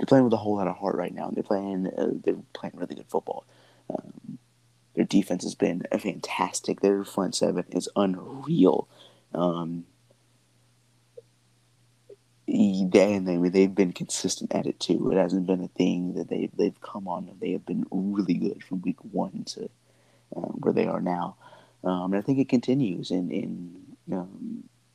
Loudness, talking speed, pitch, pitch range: -27 LUFS, 180 wpm, 95 Hz, 90-115 Hz